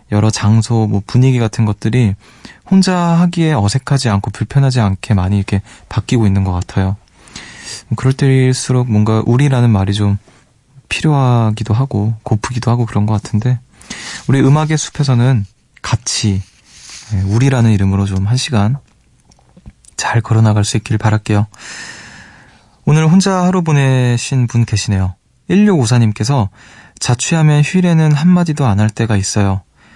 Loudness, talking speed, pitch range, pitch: -14 LUFS, 300 characters per minute, 105-130 Hz, 115 Hz